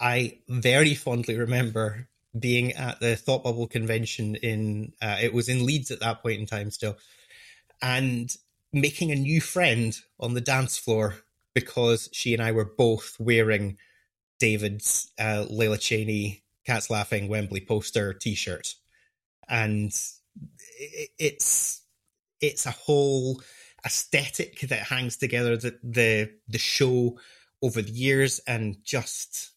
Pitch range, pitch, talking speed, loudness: 110-125 Hz, 115 Hz, 130 wpm, -26 LUFS